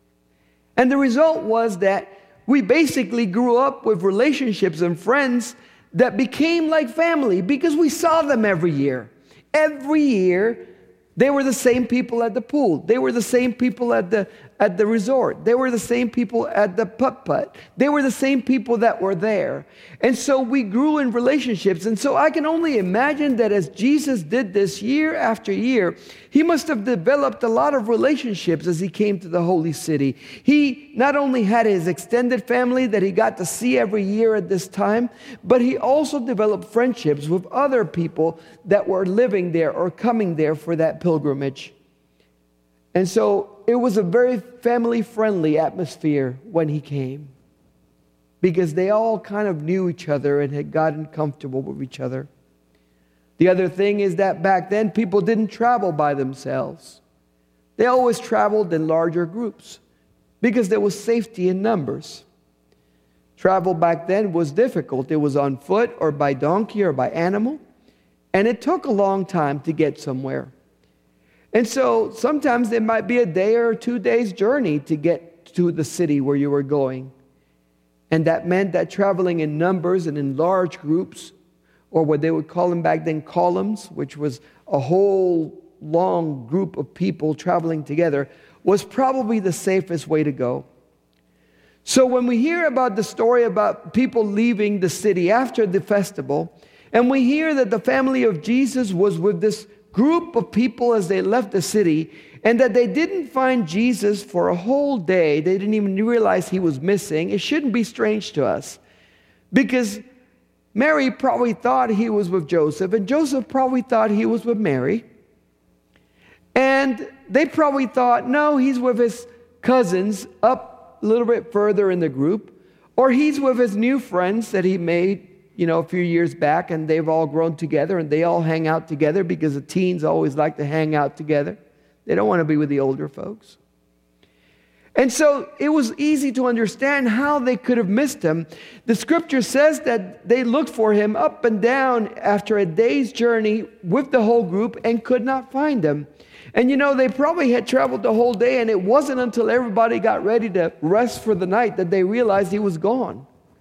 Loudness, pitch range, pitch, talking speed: -20 LUFS, 165-245 Hz, 210 Hz, 180 wpm